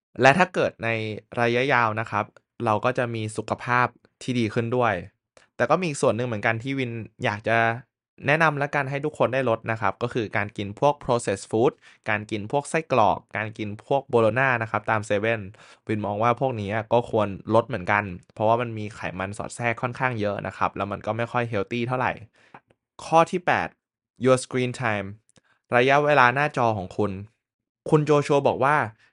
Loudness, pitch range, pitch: -24 LUFS, 105-130 Hz, 115 Hz